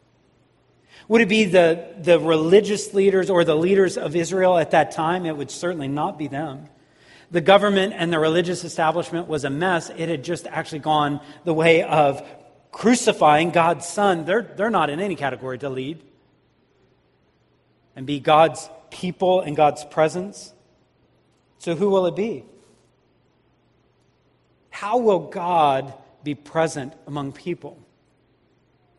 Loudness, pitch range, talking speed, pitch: -20 LUFS, 145-185 Hz, 140 wpm, 165 Hz